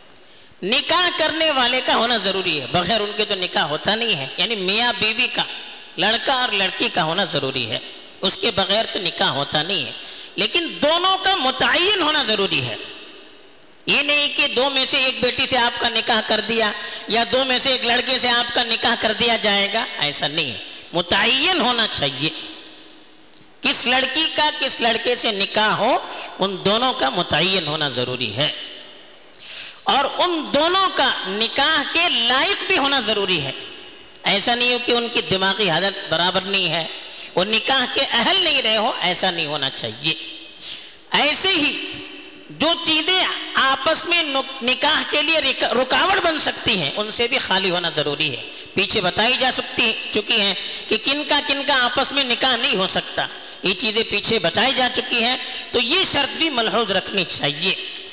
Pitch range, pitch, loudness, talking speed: 200-290 Hz, 240 Hz, -17 LUFS, 185 wpm